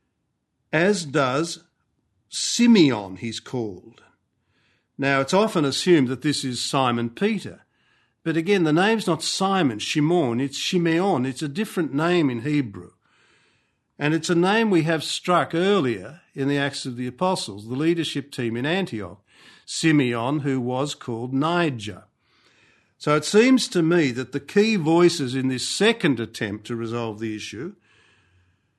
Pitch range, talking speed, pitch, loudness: 125-175 Hz, 145 wpm, 150 Hz, -22 LUFS